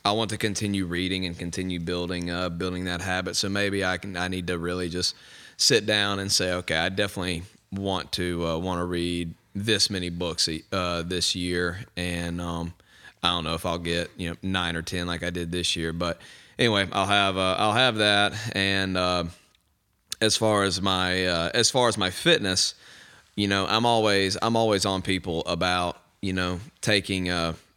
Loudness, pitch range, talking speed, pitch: -25 LUFS, 85-100 Hz, 195 wpm, 90 Hz